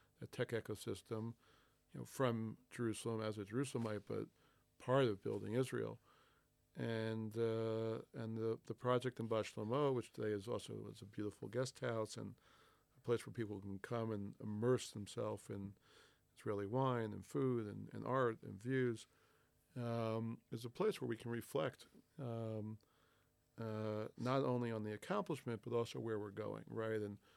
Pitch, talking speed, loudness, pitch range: 115 Hz, 160 wpm, -43 LUFS, 105-120 Hz